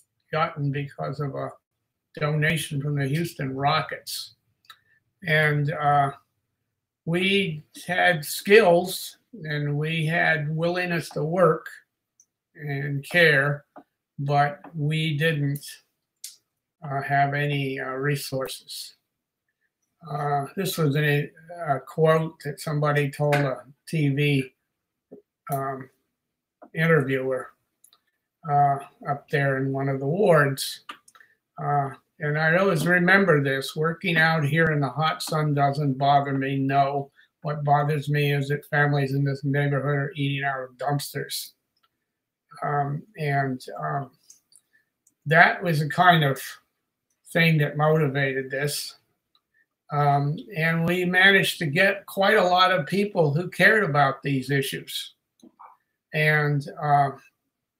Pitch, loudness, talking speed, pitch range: 145 Hz, -23 LUFS, 115 wpm, 140-165 Hz